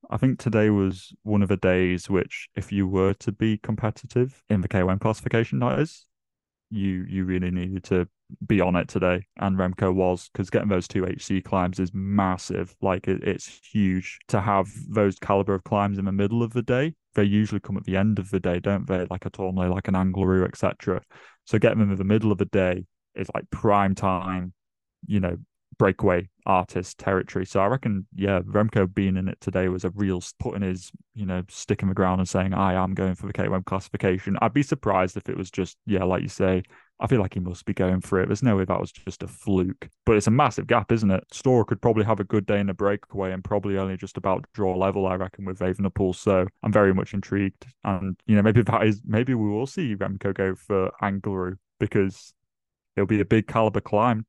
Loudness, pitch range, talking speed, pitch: -25 LUFS, 95-105 Hz, 225 wpm, 100 Hz